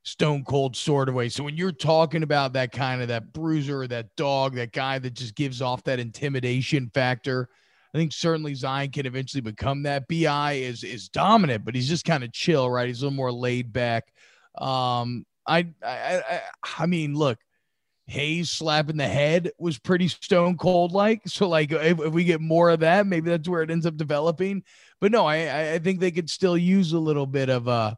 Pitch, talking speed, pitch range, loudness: 145 Hz, 210 wpm, 130-165 Hz, -24 LUFS